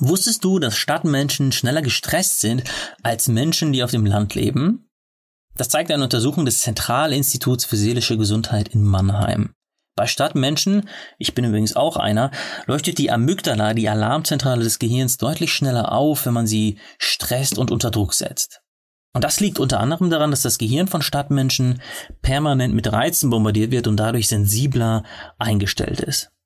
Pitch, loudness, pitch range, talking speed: 125 Hz, -19 LUFS, 110-145 Hz, 160 wpm